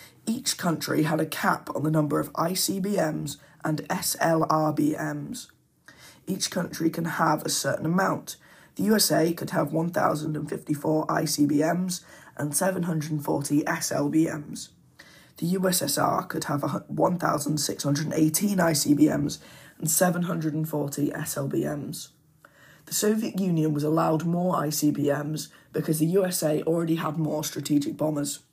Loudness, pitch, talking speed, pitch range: -26 LUFS, 155 Hz, 110 wpm, 150-170 Hz